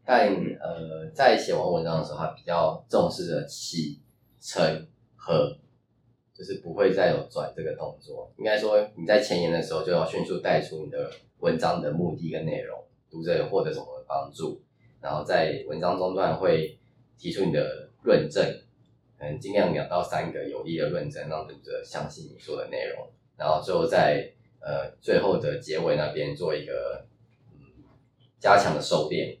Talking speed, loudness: 250 characters per minute, -27 LUFS